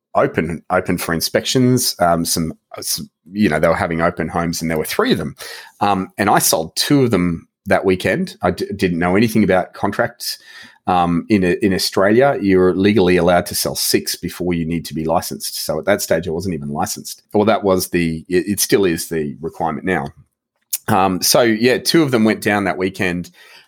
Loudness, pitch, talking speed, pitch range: -17 LUFS, 90 Hz, 210 wpm, 85-105 Hz